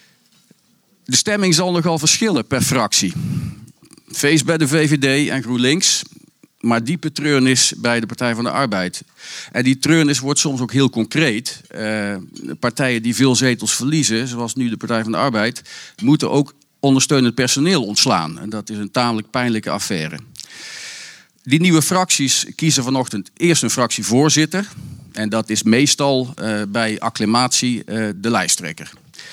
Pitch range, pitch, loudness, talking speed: 115-150 Hz, 130 Hz, -17 LUFS, 150 wpm